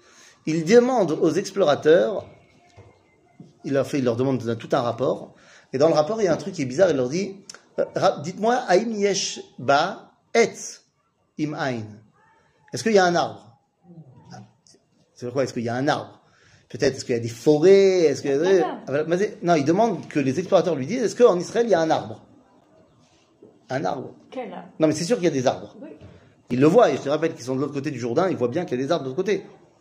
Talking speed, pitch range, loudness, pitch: 220 wpm, 135-195 Hz, -22 LUFS, 160 Hz